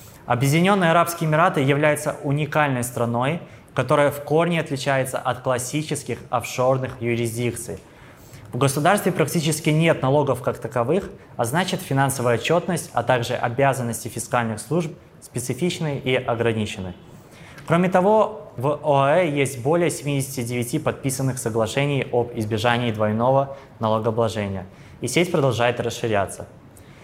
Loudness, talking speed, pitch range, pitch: -22 LUFS, 110 wpm, 120-150 Hz, 135 Hz